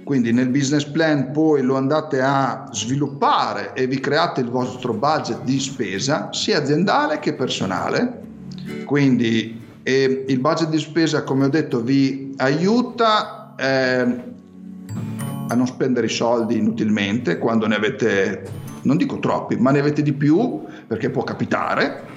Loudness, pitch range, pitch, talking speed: -20 LUFS, 125-155 Hz, 135 Hz, 140 wpm